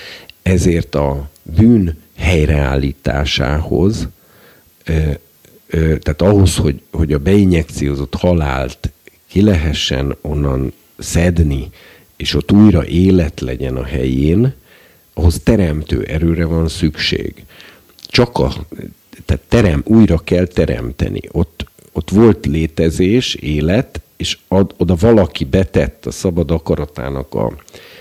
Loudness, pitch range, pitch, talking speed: -15 LUFS, 75-90 Hz, 80 Hz, 105 wpm